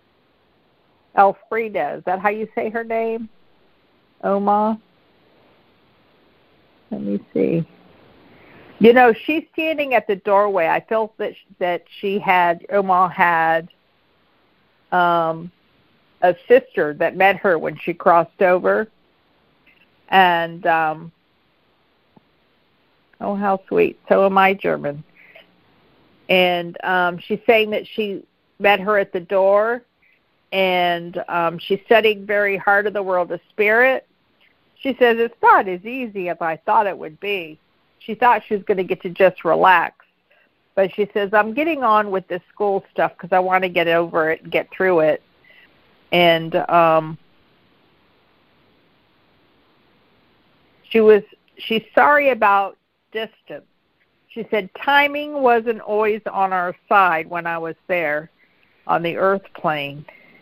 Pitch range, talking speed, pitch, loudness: 175-220 Hz, 135 wpm, 195 Hz, -18 LUFS